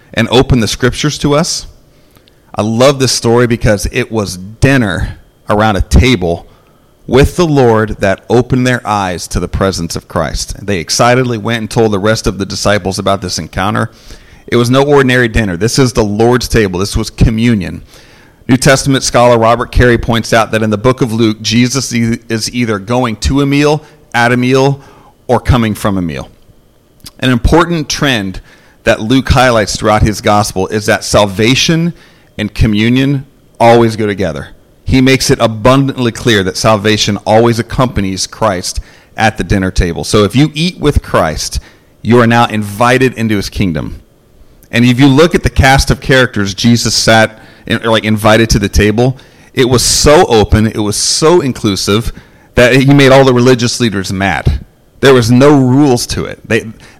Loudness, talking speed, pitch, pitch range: -10 LUFS, 175 wpm, 115 Hz, 105-130 Hz